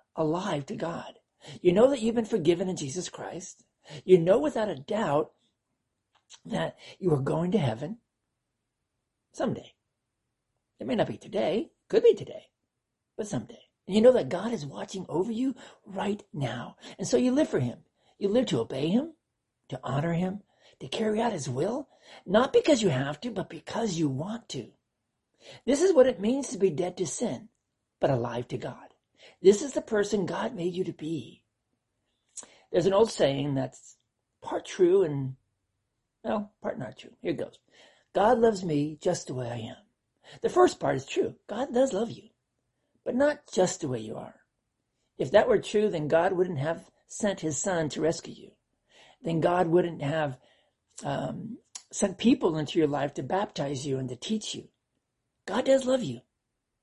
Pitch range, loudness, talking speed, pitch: 150-235 Hz, -28 LUFS, 180 wpm, 185 Hz